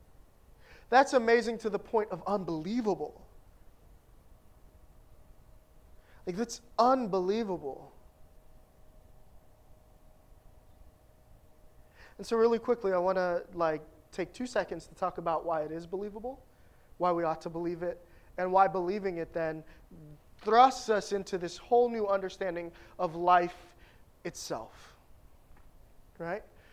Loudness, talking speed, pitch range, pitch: -31 LUFS, 110 wpm, 170-220 Hz, 185 Hz